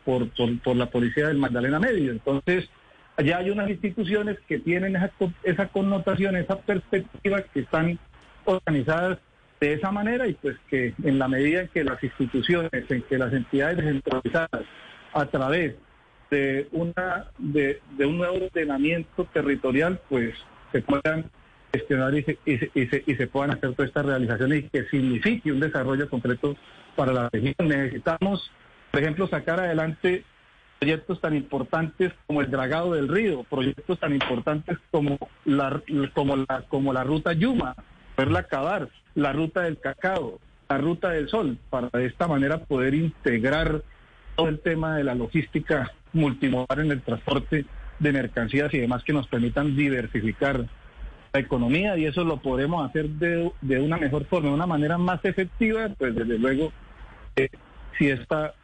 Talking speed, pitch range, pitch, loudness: 160 wpm, 135-170 Hz, 145 Hz, -25 LUFS